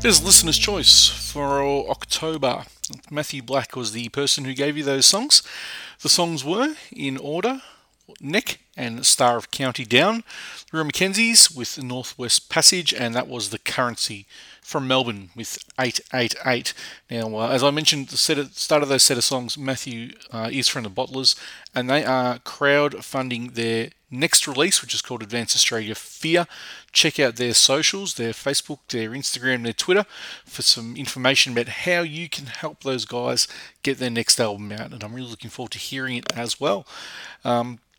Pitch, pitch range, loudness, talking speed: 130 Hz, 120-145 Hz, -20 LUFS, 170 wpm